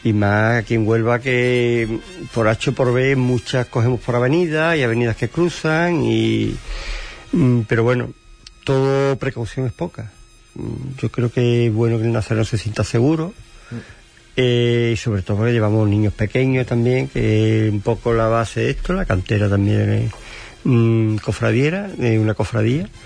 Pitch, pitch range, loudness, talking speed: 115 Hz, 110-125 Hz, -18 LUFS, 165 wpm